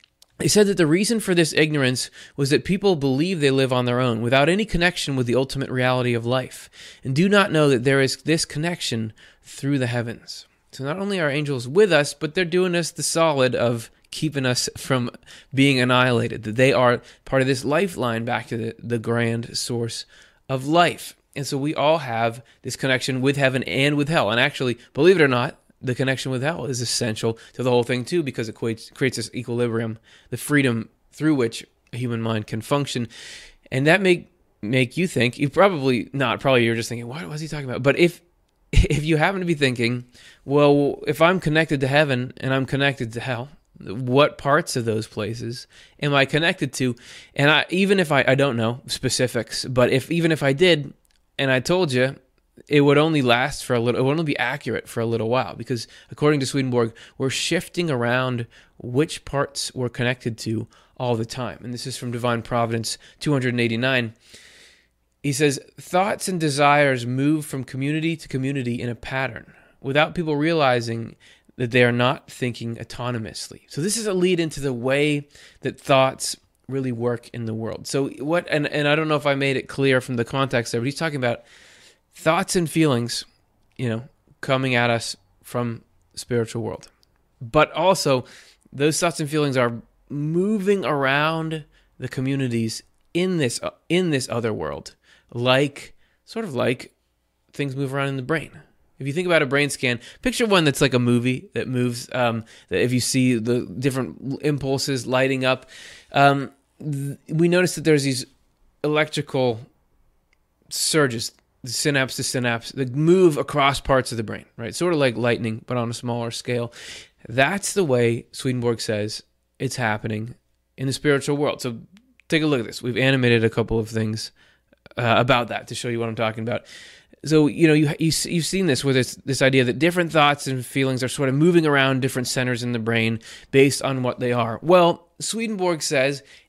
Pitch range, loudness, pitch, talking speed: 120-150 Hz, -22 LUFS, 130 Hz, 190 wpm